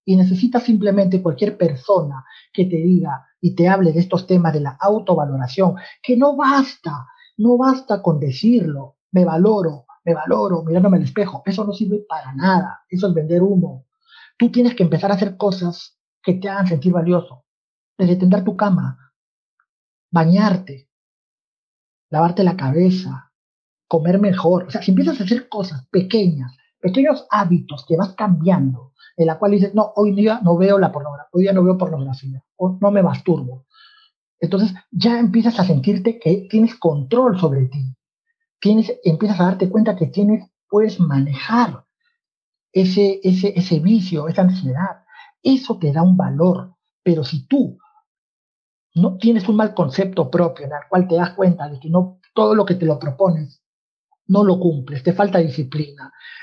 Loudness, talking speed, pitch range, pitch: -17 LUFS, 165 wpm, 165-210 Hz, 185 Hz